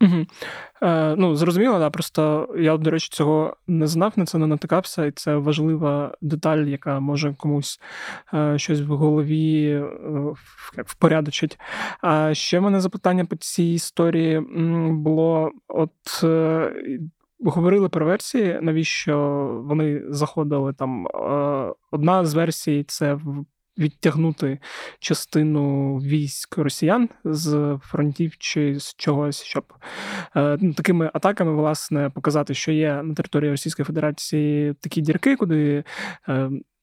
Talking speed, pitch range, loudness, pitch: 115 wpm, 145-165 Hz, -22 LUFS, 155 Hz